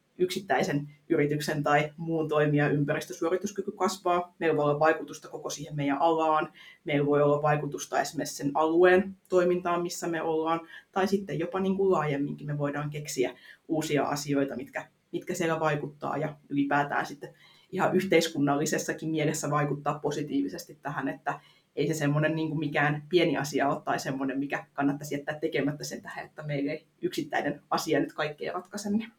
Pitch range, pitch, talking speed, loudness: 145-175 Hz, 155 Hz, 155 wpm, -29 LUFS